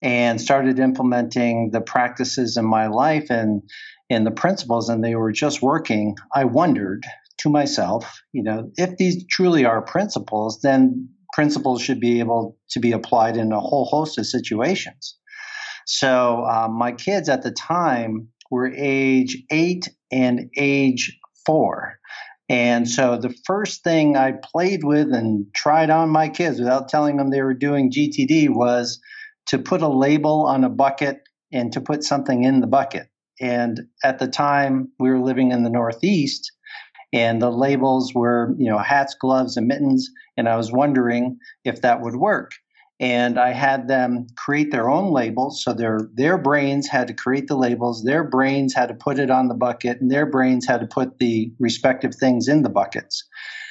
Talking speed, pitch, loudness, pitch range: 175 wpm, 130 Hz, -20 LUFS, 120-145 Hz